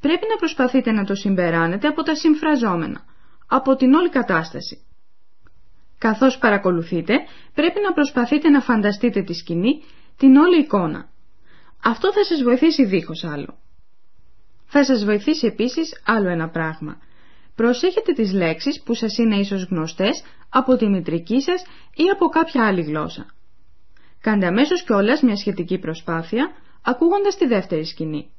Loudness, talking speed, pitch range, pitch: -19 LUFS, 135 wpm, 175-295 Hz, 230 Hz